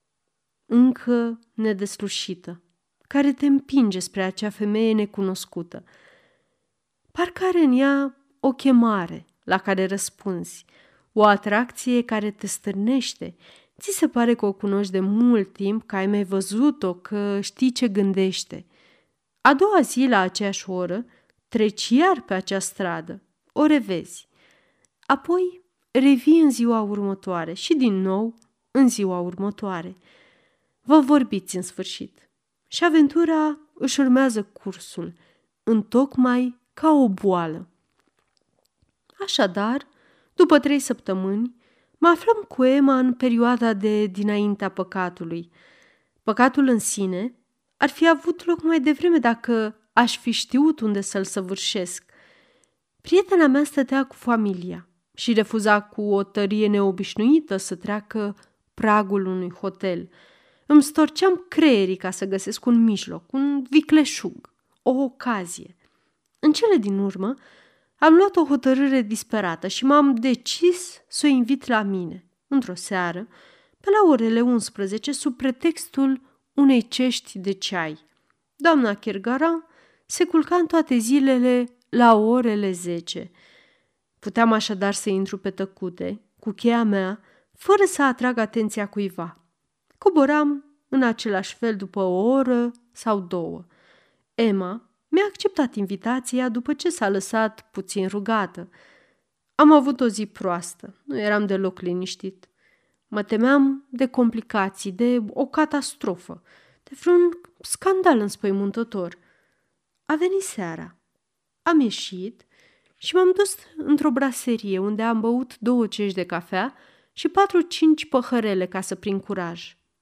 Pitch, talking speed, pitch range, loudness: 230 Hz, 125 wpm, 195-275 Hz, -22 LUFS